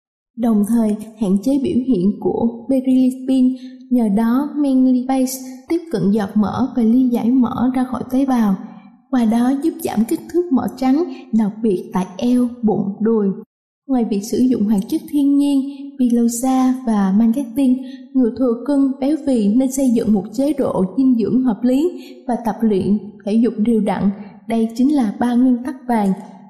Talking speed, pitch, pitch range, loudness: 175 wpm, 245 Hz, 215-260 Hz, -17 LUFS